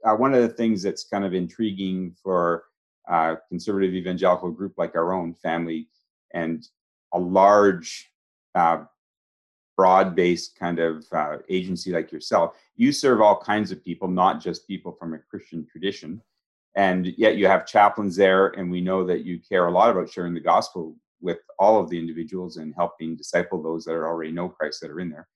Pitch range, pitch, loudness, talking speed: 85-95 Hz, 90 Hz, -23 LUFS, 185 wpm